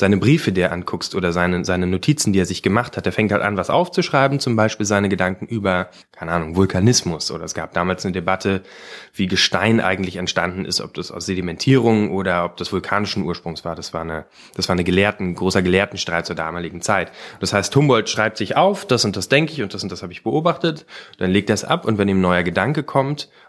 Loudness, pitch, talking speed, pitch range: -19 LUFS, 95 Hz, 230 wpm, 90-110 Hz